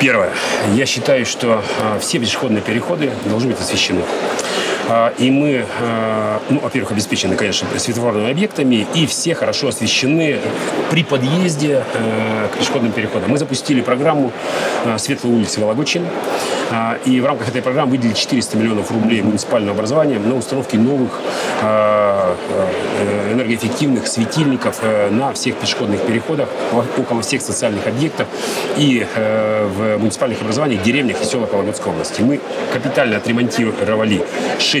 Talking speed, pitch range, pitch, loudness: 120 wpm, 110-130 Hz, 115 Hz, -16 LUFS